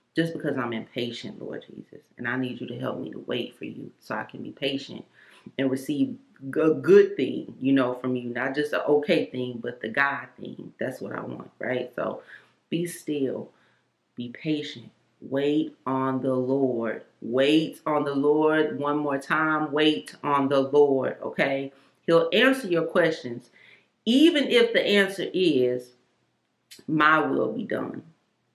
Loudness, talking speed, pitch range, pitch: -25 LUFS, 170 wpm, 130-155 Hz, 140 Hz